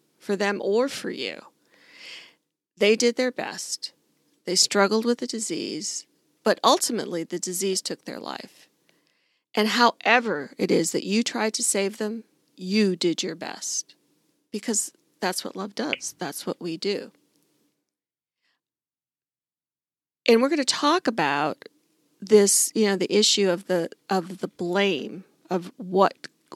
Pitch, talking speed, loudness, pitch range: 205 Hz, 140 wpm, -24 LUFS, 190-235 Hz